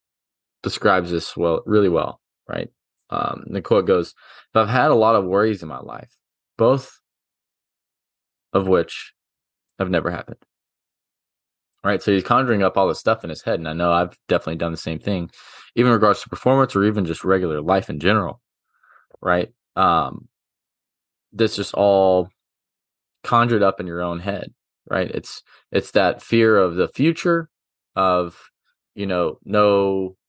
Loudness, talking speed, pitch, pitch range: -20 LUFS, 160 wpm, 100 Hz, 90-110 Hz